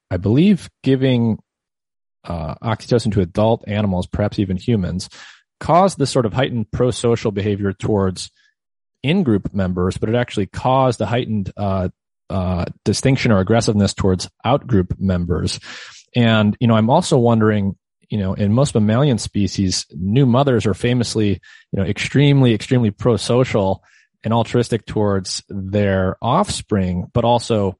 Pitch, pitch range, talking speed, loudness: 110 Hz, 95-120 Hz, 135 wpm, -18 LUFS